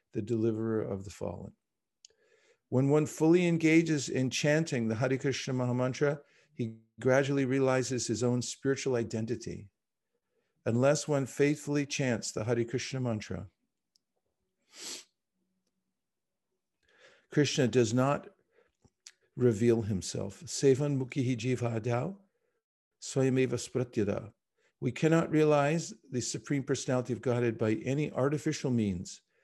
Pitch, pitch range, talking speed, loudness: 130 Hz, 120-145 Hz, 100 wpm, -30 LUFS